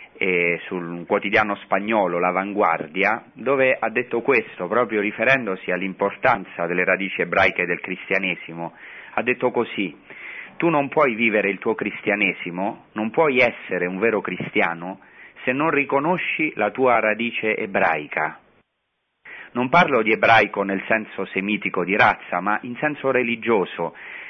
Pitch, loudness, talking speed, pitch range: 105 Hz, -21 LUFS, 130 wpm, 95-115 Hz